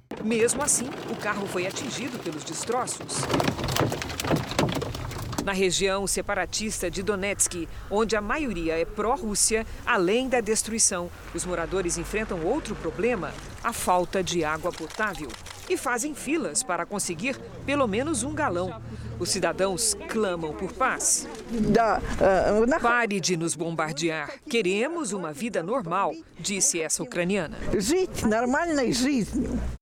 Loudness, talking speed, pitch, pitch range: -26 LUFS, 115 wpm, 205 Hz, 175-235 Hz